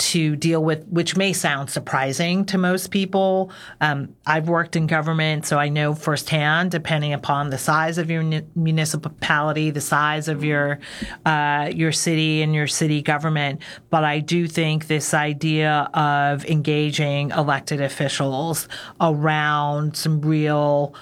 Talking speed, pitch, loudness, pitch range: 145 wpm, 155 Hz, -21 LUFS, 150-165 Hz